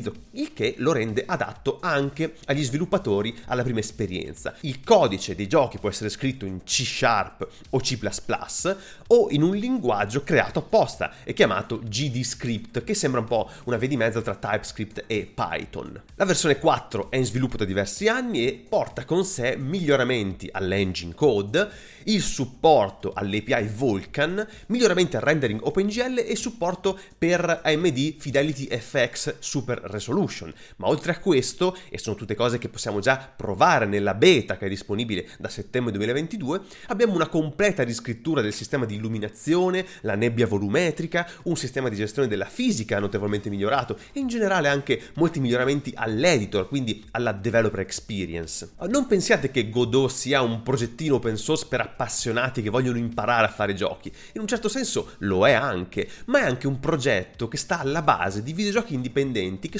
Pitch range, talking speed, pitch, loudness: 110-165 Hz, 165 wpm, 130 Hz, -24 LUFS